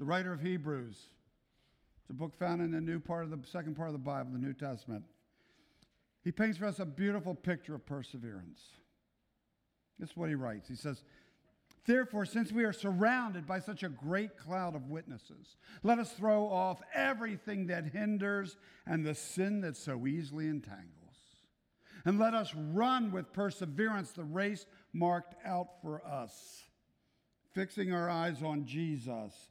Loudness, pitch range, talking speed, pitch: -37 LUFS, 150-200 Hz, 165 wpm, 175 Hz